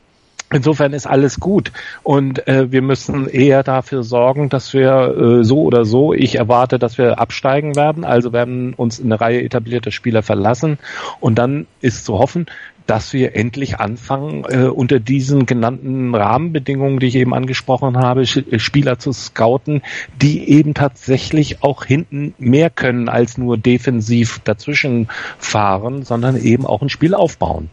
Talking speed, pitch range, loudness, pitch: 155 wpm, 120-140 Hz, -15 LUFS, 130 Hz